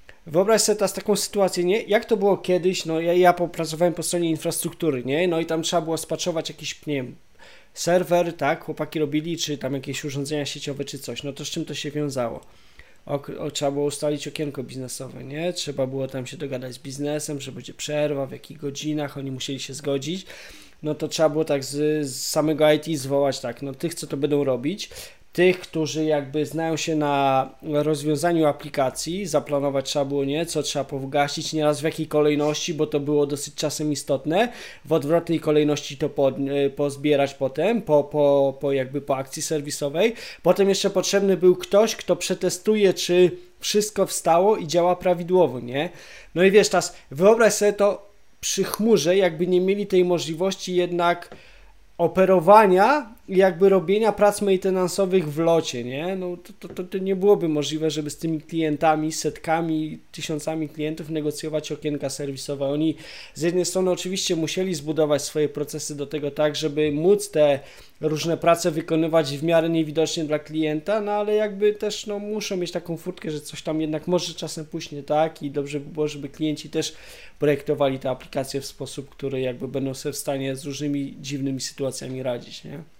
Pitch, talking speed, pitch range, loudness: 155 Hz, 175 wpm, 145-180 Hz, -23 LUFS